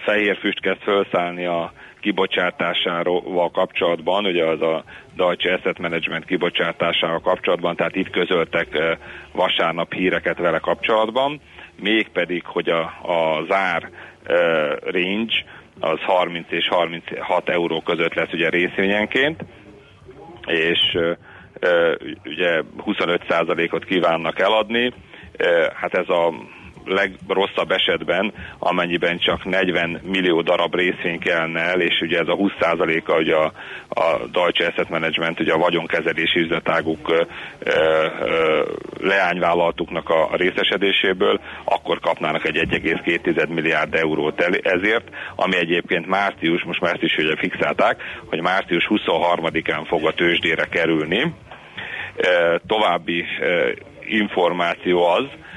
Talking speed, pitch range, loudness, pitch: 115 wpm, 85-115 Hz, -20 LUFS, 90 Hz